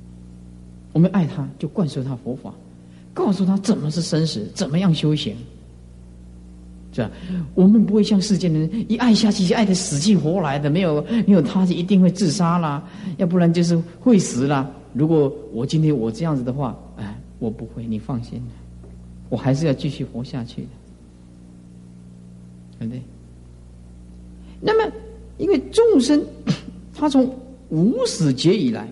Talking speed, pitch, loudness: 230 characters per minute, 145 Hz, -20 LUFS